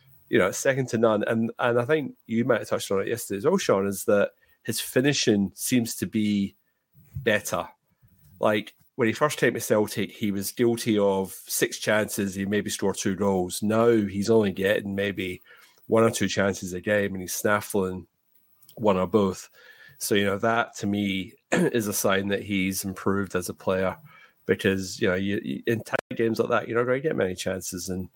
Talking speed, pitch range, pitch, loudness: 200 wpm, 95-115 Hz, 100 Hz, -25 LUFS